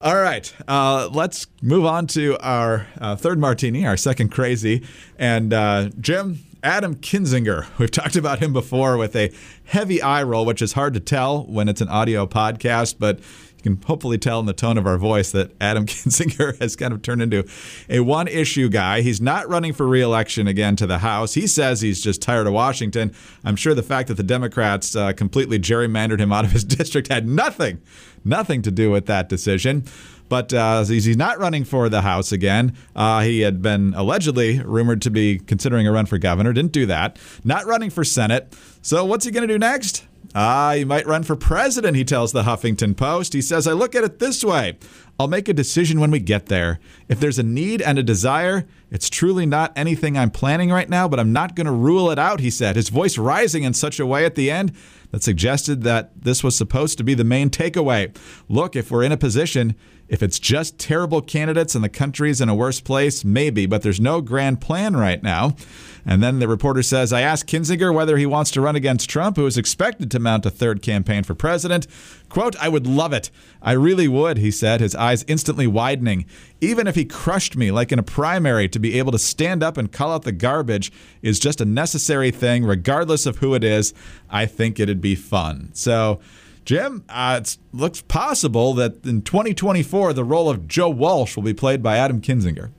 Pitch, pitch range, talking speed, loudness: 125 Hz, 110-150 Hz, 215 wpm, -19 LUFS